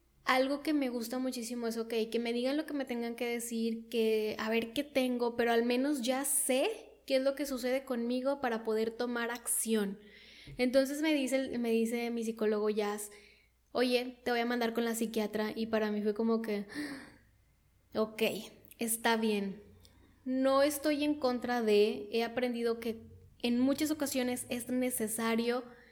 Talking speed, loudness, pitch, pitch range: 170 wpm, -33 LUFS, 240 Hz, 225-260 Hz